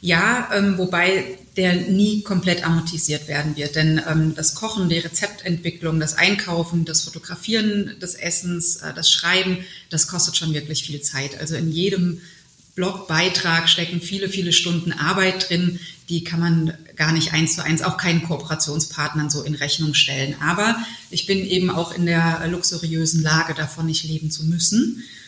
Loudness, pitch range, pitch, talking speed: -19 LUFS, 155-180 Hz, 170 Hz, 155 wpm